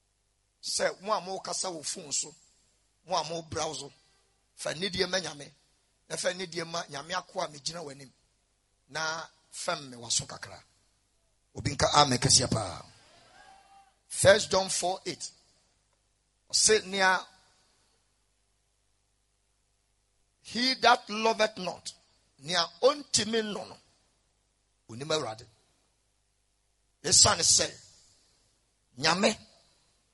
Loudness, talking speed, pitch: -27 LUFS, 90 wpm, 145 Hz